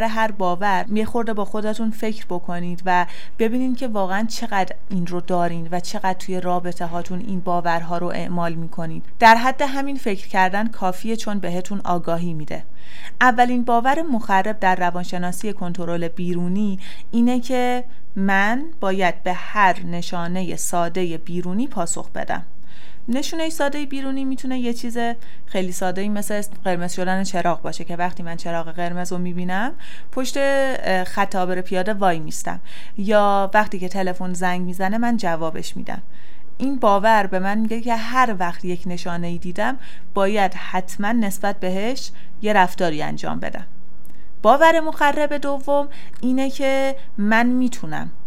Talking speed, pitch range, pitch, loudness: 145 wpm, 180-235 Hz, 195 Hz, -22 LUFS